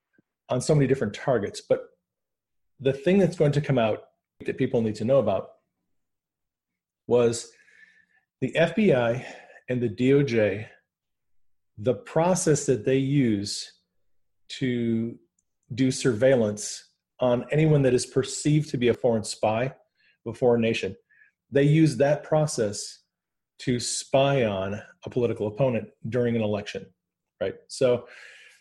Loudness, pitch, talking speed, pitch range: -25 LUFS, 130 Hz, 130 wpm, 115-150 Hz